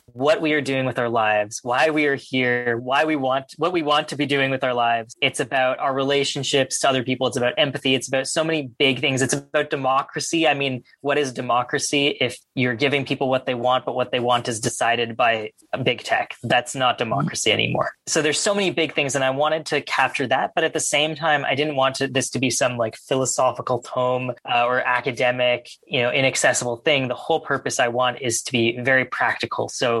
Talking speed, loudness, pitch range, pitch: 230 wpm, -21 LUFS, 125-145 Hz, 135 Hz